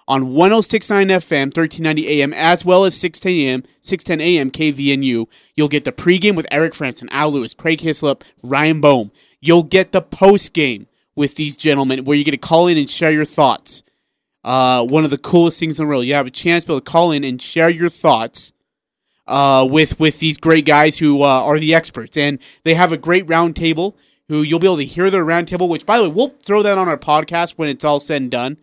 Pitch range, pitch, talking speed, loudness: 145-170 Hz, 155 Hz, 225 wpm, -15 LUFS